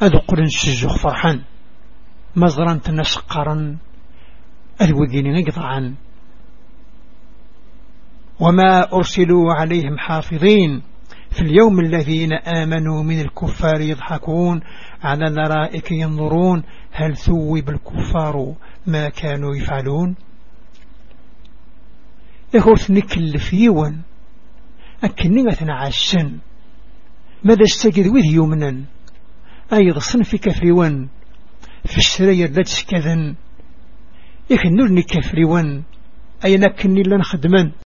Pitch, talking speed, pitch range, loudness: 165 Hz, 80 wpm, 150-190 Hz, -16 LUFS